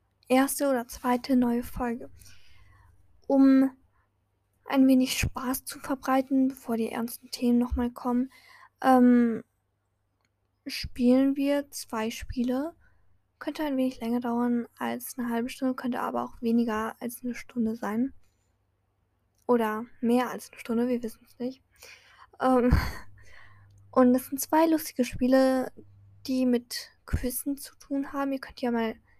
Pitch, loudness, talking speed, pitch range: 245 Hz, -27 LUFS, 135 wpm, 220-265 Hz